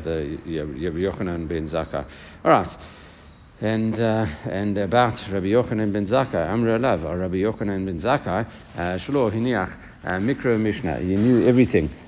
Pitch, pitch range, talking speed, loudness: 95 Hz, 80-110 Hz, 180 wpm, -23 LUFS